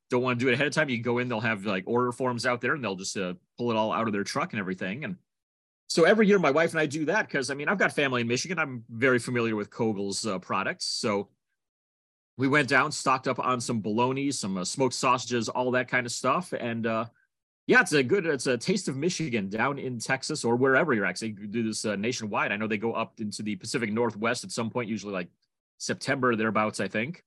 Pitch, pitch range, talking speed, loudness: 120 Hz, 110-130 Hz, 260 wpm, -27 LUFS